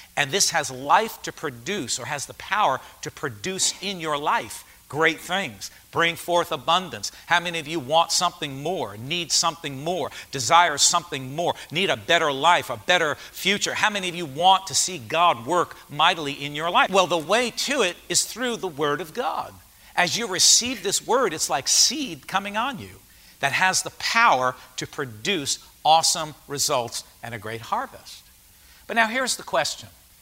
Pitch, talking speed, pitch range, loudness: 170 Hz, 185 wpm, 145-190 Hz, -22 LUFS